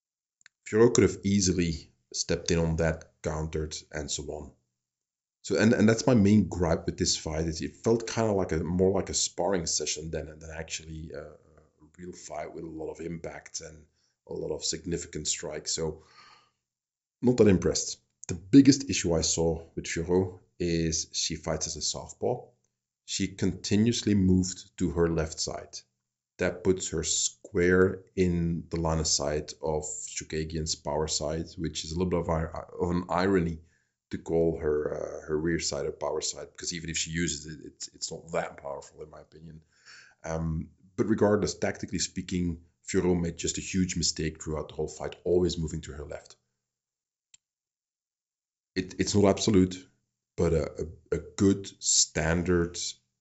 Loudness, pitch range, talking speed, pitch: -28 LUFS, 80-90 Hz, 170 wpm, 85 Hz